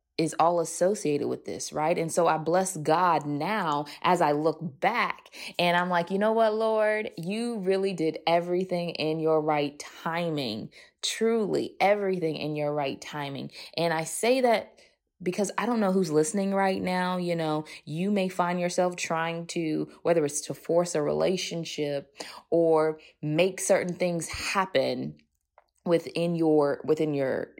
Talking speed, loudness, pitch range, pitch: 155 wpm, -27 LUFS, 155-190 Hz, 170 Hz